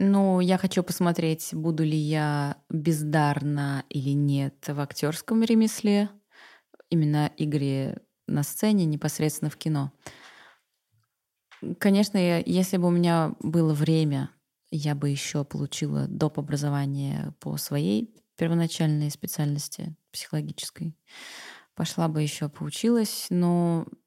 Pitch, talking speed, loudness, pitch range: 155 Hz, 110 wpm, -26 LUFS, 145-180 Hz